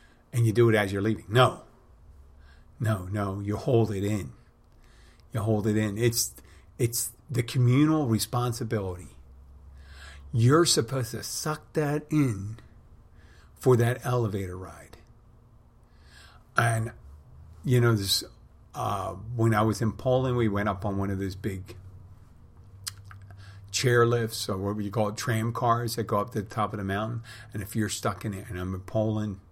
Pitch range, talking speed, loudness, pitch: 95-115 Hz, 160 wpm, -27 LUFS, 105 Hz